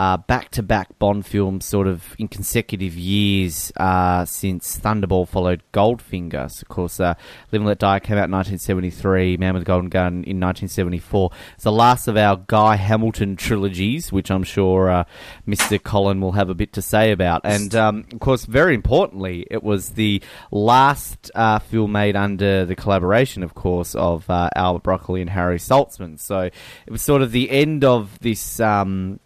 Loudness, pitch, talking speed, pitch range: -19 LUFS, 100 Hz, 180 wpm, 90-105 Hz